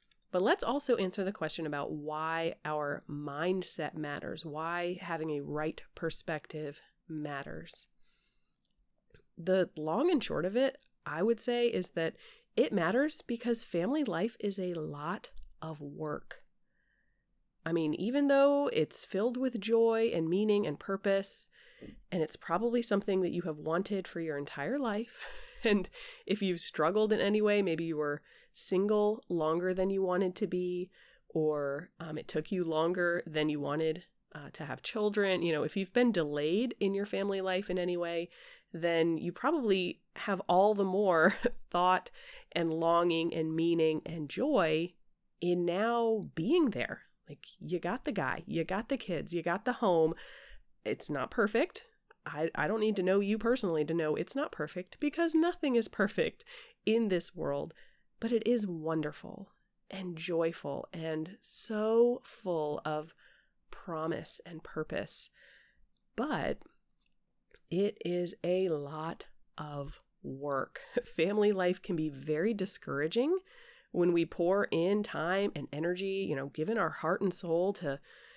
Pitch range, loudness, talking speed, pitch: 160-215 Hz, -33 LUFS, 155 wpm, 180 Hz